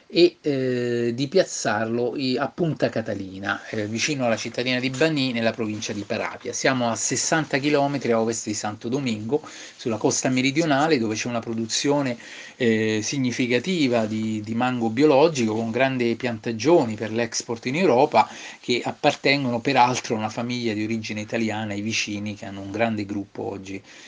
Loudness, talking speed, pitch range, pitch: -23 LUFS, 155 wpm, 110-130 Hz, 120 Hz